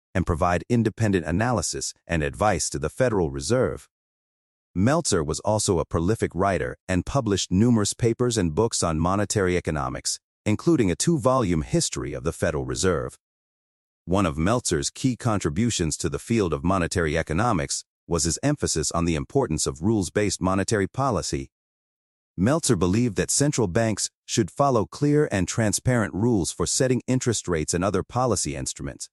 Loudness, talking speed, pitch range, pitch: -24 LUFS, 155 wpm, 85-120 Hz, 95 Hz